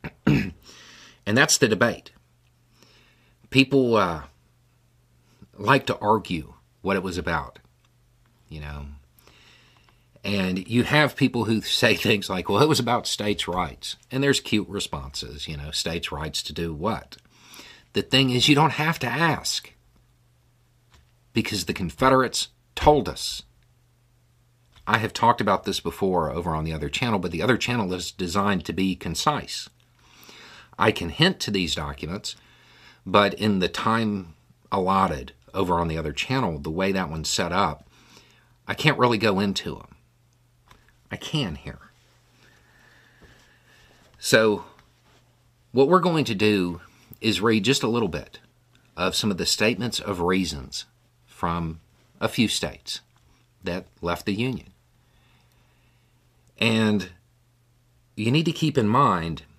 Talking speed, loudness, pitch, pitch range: 140 wpm, -23 LUFS, 105 Hz, 85-120 Hz